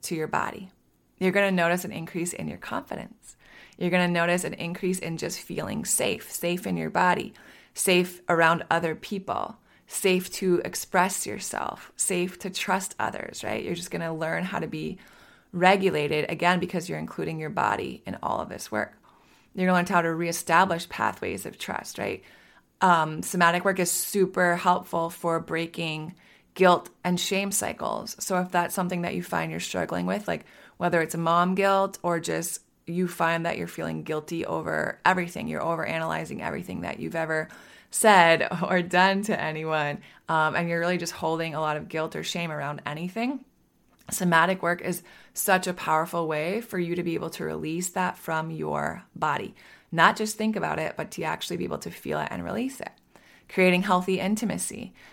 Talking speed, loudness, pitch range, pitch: 185 wpm, -26 LUFS, 165-185 Hz, 175 Hz